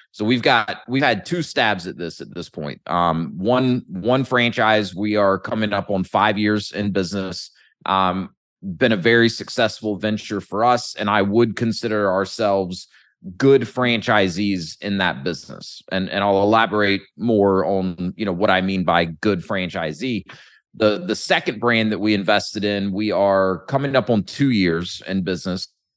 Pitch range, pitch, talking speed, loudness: 95-115 Hz, 105 Hz, 170 wpm, -20 LUFS